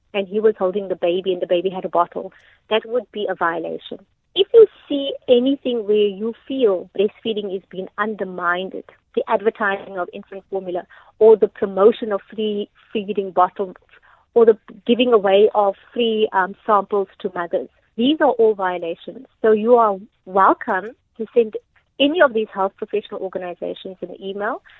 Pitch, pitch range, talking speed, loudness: 205 Hz, 190-225 Hz, 165 wpm, -19 LUFS